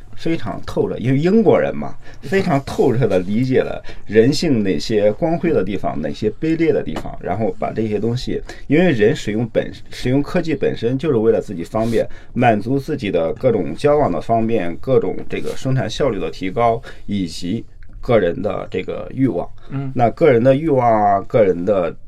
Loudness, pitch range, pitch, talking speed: -18 LUFS, 105-145 Hz, 115 Hz, 285 characters per minute